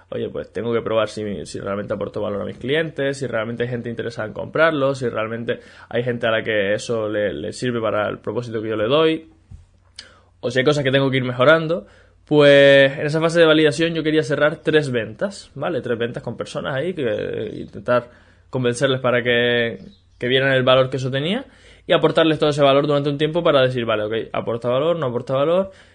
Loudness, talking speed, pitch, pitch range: -19 LUFS, 215 wpm, 130 Hz, 115-150 Hz